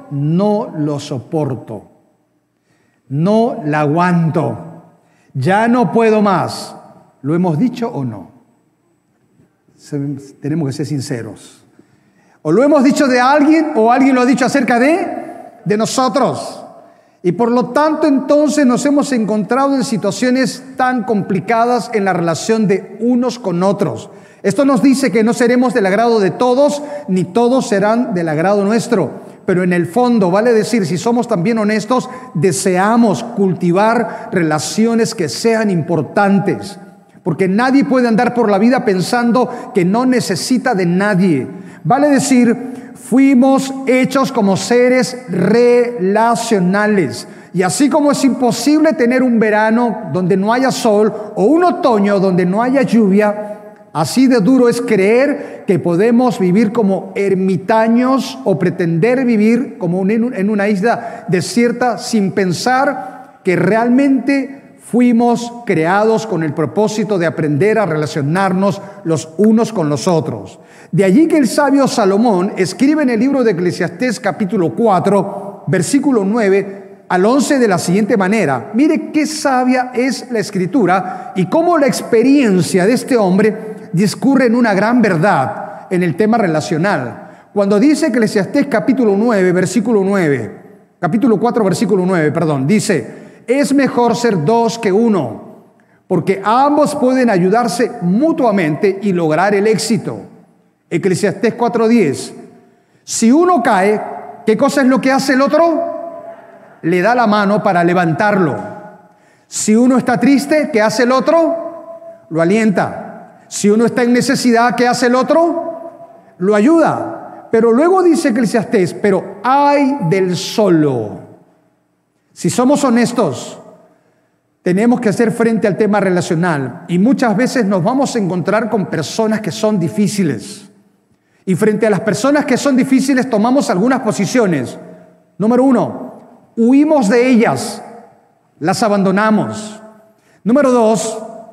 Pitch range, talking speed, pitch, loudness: 190-250 Hz, 135 wpm, 220 Hz, -13 LUFS